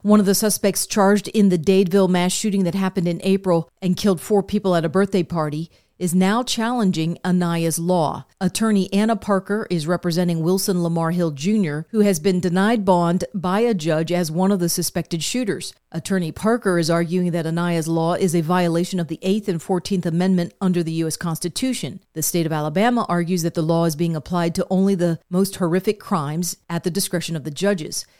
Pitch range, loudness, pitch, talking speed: 170-195 Hz, -20 LUFS, 180 Hz, 200 wpm